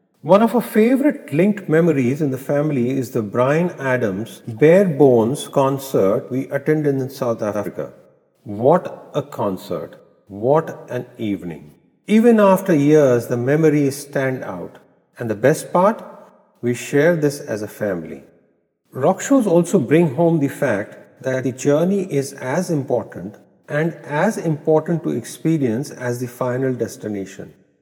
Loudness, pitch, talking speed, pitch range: -18 LUFS, 140 Hz, 140 wpm, 125-165 Hz